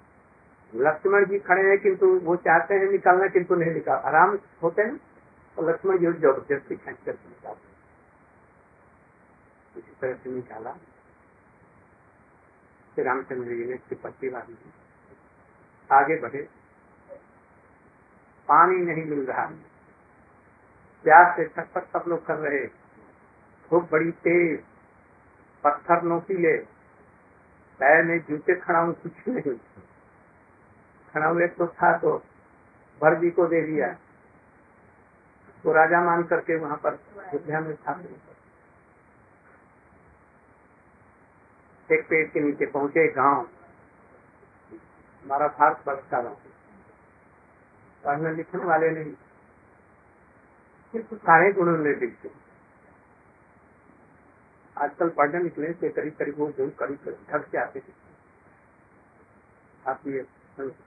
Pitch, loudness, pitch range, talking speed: 165 Hz, -24 LUFS, 150-180 Hz, 105 wpm